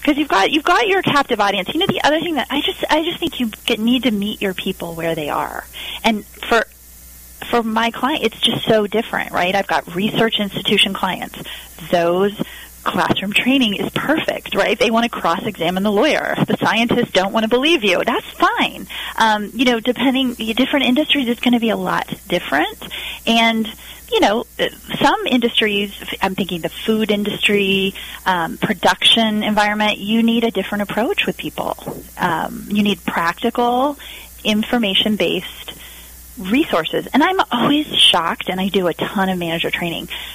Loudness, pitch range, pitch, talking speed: -17 LUFS, 195-250 Hz, 220 Hz, 170 wpm